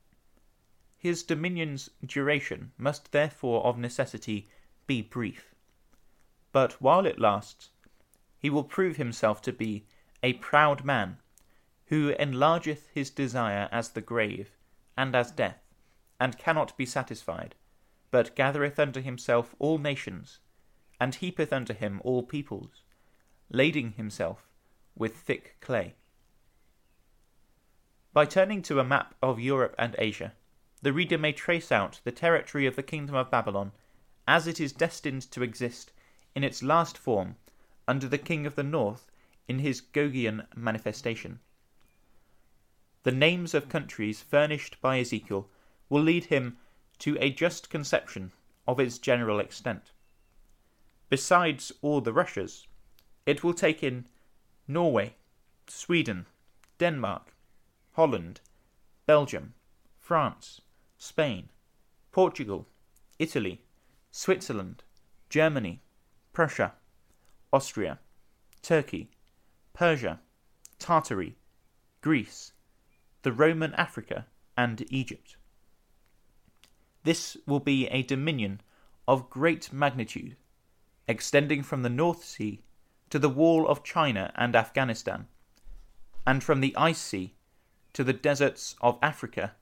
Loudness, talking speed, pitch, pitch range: -29 LUFS, 115 wpm, 130 Hz, 115-150 Hz